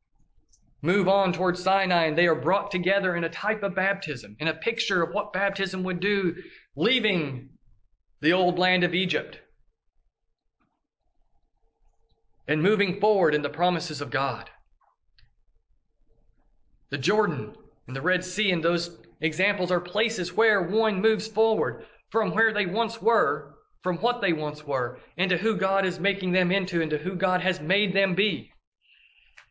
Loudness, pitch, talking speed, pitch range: -25 LUFS, 180 Hz, 150 wpm, 150-200 Hz